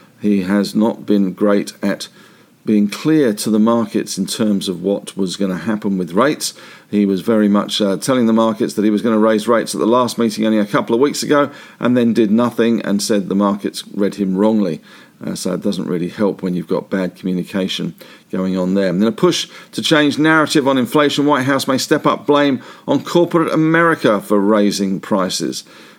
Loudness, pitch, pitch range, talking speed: -16 LUFS, 105 Hz, 100-125 Hz, 210 wpm